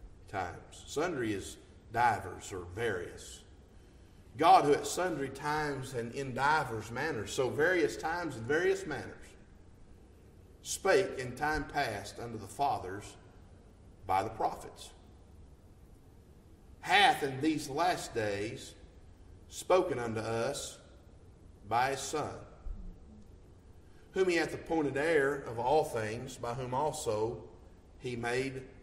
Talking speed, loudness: 115 wpm, -33 LUFS